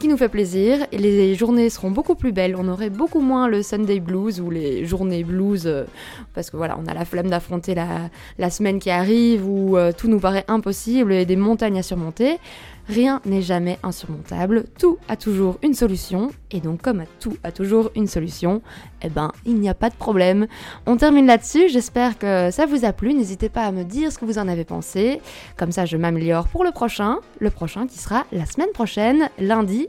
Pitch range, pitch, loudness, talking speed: 185-235 Hz, 205 Hz, -20 LUFS, 215 wpm